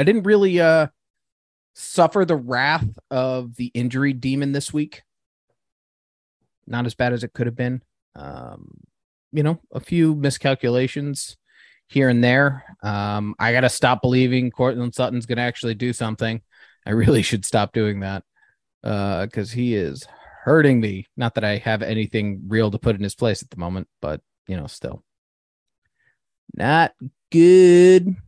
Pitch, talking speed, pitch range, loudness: 120 Hz, 160 wpm, 110-140 Hz, -20 LUFS